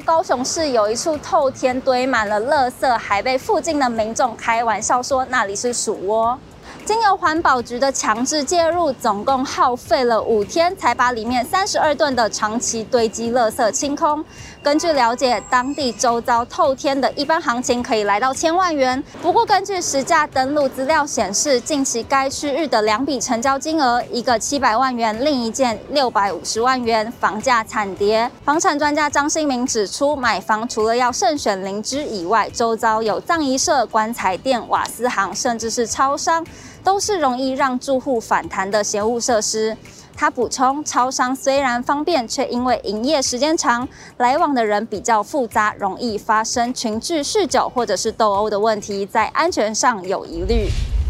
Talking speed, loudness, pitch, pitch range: 265 characters per minute, -18 LUFS, 250 Hz, 225-290 Hz